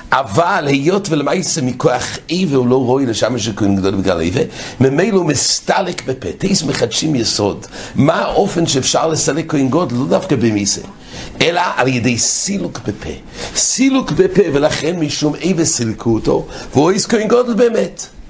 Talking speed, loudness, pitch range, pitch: 150 wpm, -14 LUFS, 125-175 Hz, 145 Hz